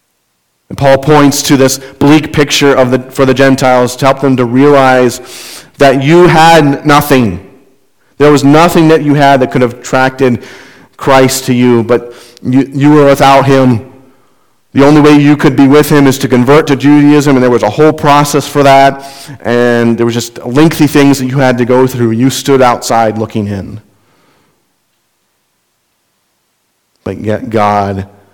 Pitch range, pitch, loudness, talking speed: 125-145 Hz, 135 Hz, -7 LUFS, 170 wpm